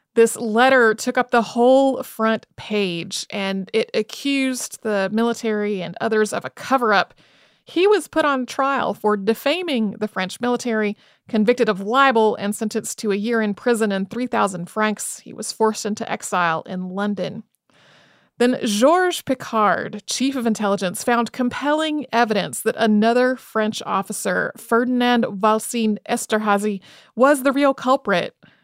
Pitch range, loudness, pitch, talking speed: 210-250 Hz, -20 LUFS, 225 Hz, 145 wpm